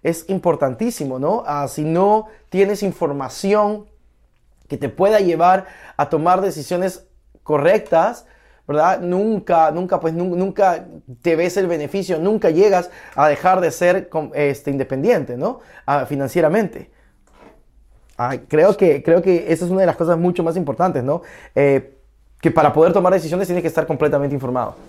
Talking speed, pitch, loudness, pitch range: 150 wpm, 175 Hz, -18 LUFS, 150-190 Hz